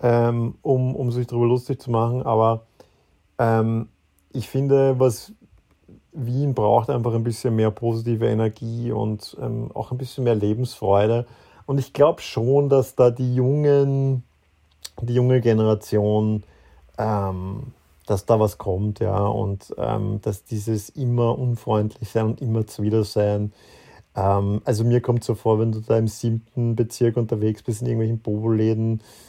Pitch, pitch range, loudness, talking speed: 115 Hz, 105-125 Hz, -22 LUFS, 150 wpm